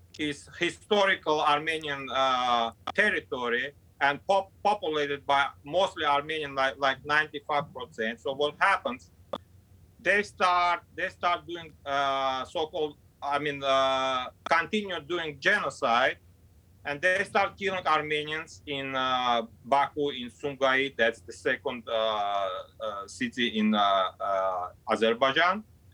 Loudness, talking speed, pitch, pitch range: -28 LUFS, 120 wpm, 140 Hz, 120-155 Hz